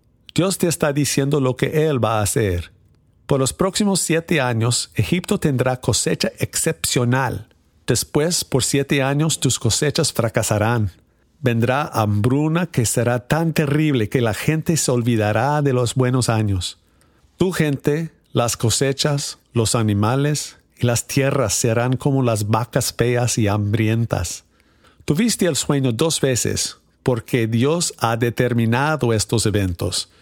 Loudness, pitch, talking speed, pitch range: -19 LUFS, 125 Hz, 135 wpm, 110-150 Hz